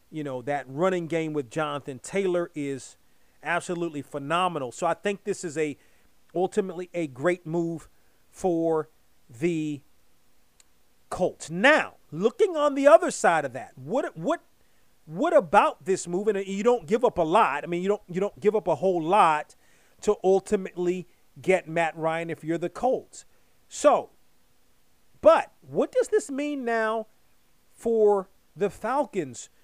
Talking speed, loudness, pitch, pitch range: 150 wpm, -26 LUFS, 180 Hz, 160-210 Hz